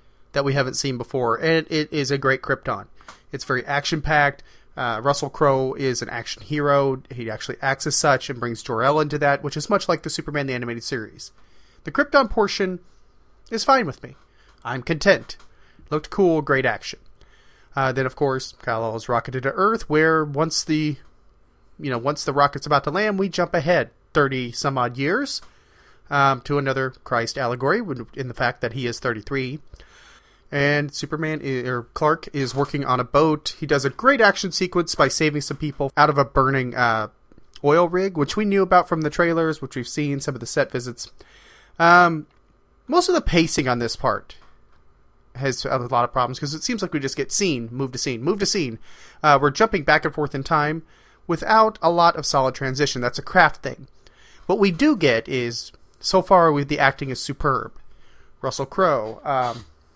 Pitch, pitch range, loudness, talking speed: 140 Hz, 130-160 Hz, -21 LUFS, 195 wpm